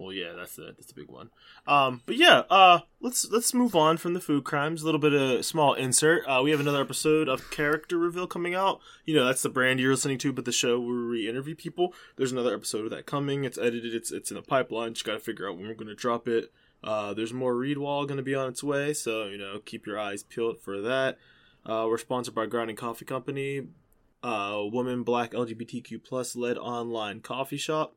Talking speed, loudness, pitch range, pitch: 235 wpm, -27 LUFS, 115-150 Hz, 130 Hz